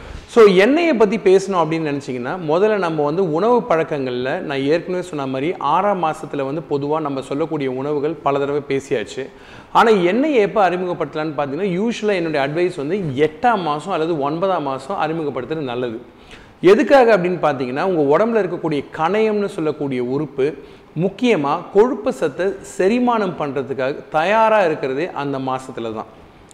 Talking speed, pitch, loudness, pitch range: 135 wpm, 160 Hz, -18 LUFS, 140-200 Hz